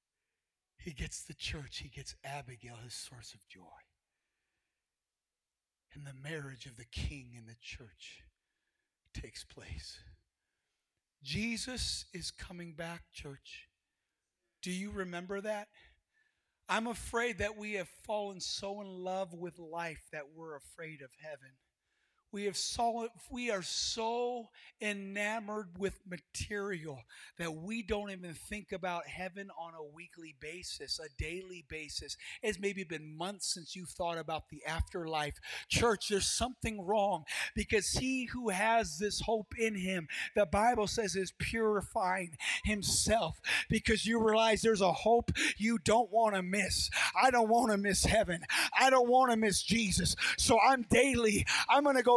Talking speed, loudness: 145 wpm, -33 LUFS